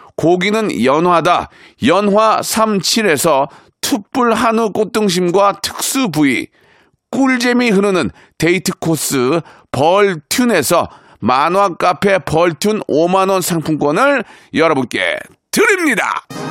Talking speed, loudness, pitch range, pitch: 205 characters per minute, -14 LUFS, 180-240 Hz, 205 Hz